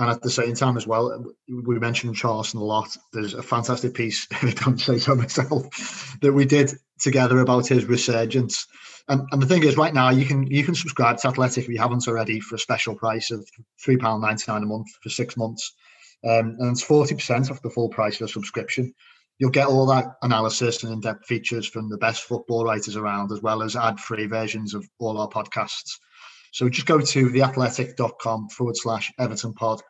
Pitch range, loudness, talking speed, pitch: 110-130 Hz, -23 LUFS, 205 wpm, 120 Hz